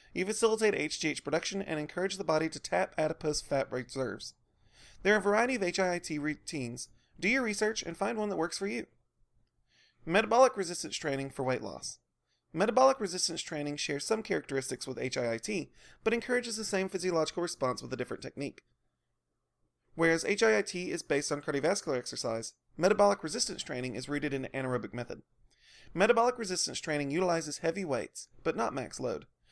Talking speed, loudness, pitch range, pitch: 165 wpm, -32 LUFS, 140-200 Hz, 165 Hz